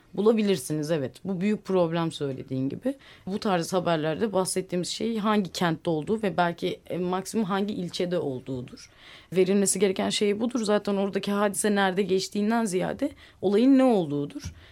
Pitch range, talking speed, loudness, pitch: 170-210 Hz, 140 wpm, -26 LUFS, 190 Hz